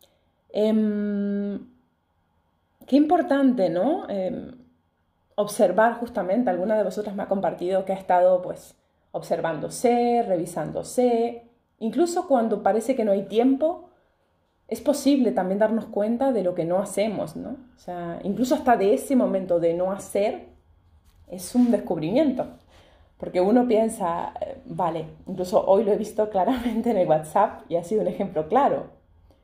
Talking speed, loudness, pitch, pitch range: 145 wpm, -23 LUFS, 205 Hz, 180-250 Hz